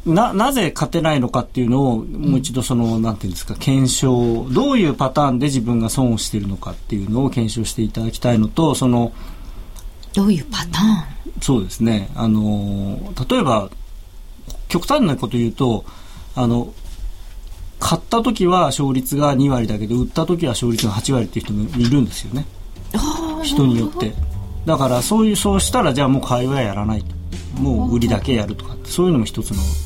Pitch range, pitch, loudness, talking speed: 105-140 Hz, 120 Hz, -18 LUFS, 370 characters per minute